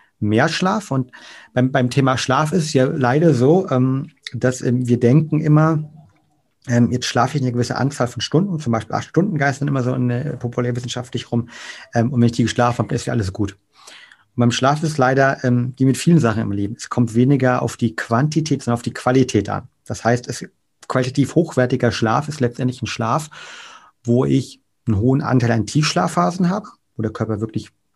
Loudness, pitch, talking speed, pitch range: -19 LUFS, 125 Hz, 195 wpm, 120-145 Hz